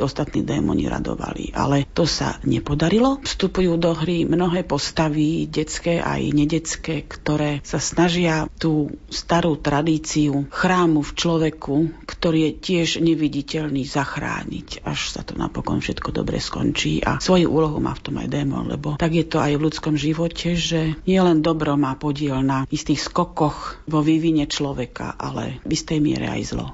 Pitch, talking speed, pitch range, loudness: 155 Hz, 155 wpm, 150-165 Hz, -21 LUFS